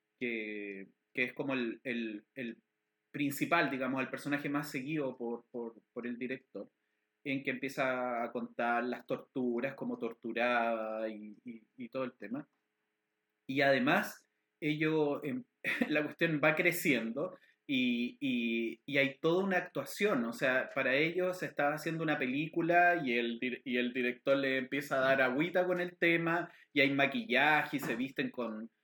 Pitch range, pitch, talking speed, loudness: 120-155 Hz, 135 Hz, 160 wpm, -33 LUFS